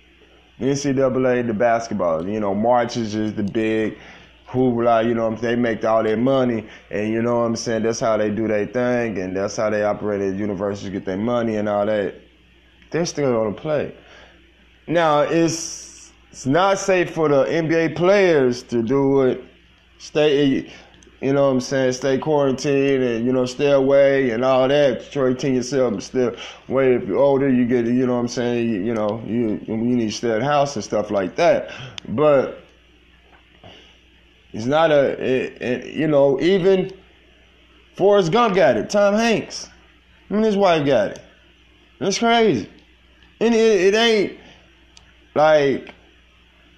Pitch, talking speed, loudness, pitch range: 125 Hz, 175 wpm, -19 LUFS, 105-140 Hz